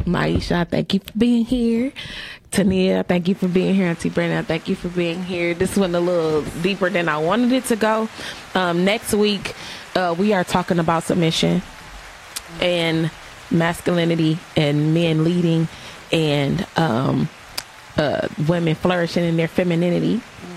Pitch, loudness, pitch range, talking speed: 175 Hz, -20 LUFS, 165-195 Hz, 150 wpm